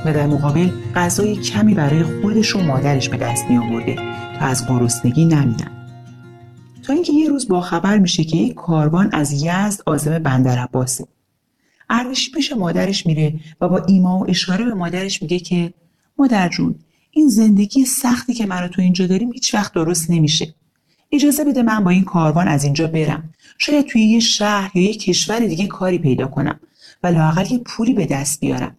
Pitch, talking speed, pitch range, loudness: 175 Hz, 170 wpm, 150-210 Hz, -17 LUFS